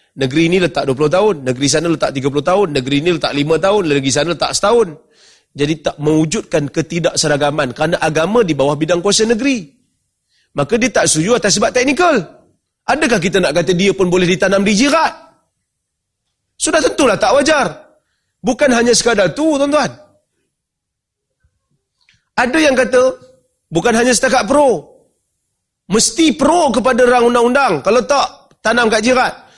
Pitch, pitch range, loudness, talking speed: 200 Hz, 155-255 Hz, -13 LUFS, 150 wpm